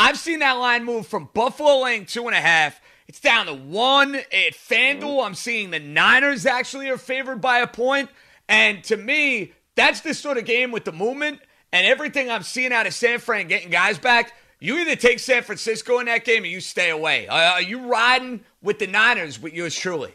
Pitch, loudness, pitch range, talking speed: 240 Hz, -19 LUFS, 215-265 Hz, 215 wpm